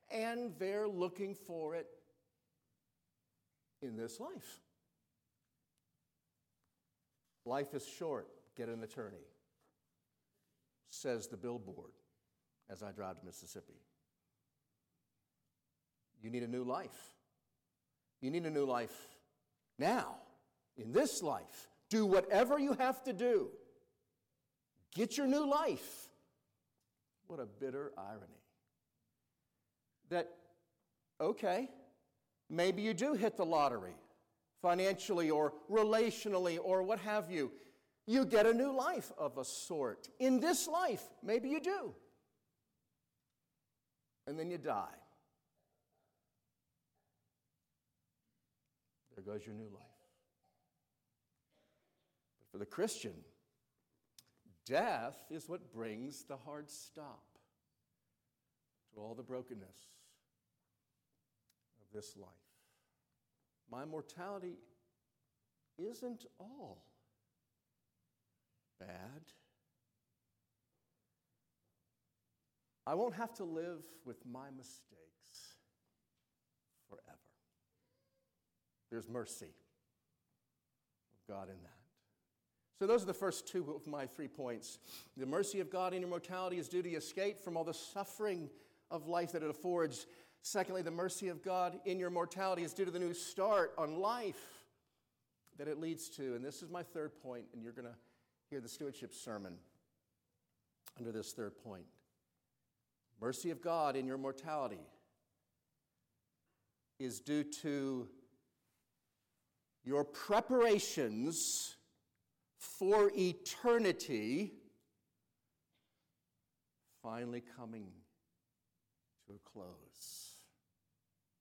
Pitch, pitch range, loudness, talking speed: 160 Hz, 125-195 Hz, -39 LUFS, 105 wpm